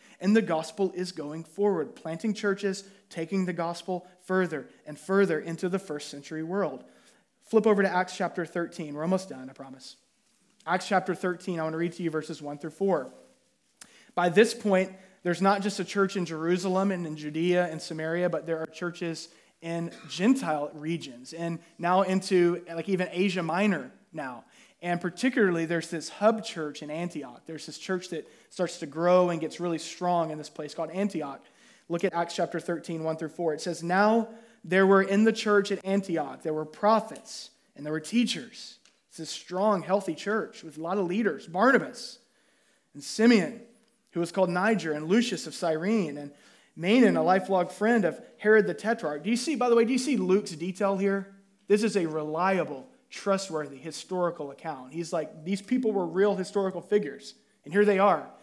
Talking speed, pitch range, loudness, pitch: 190 wpm, 165-205 Hz, -28 LUFS, 180 Hz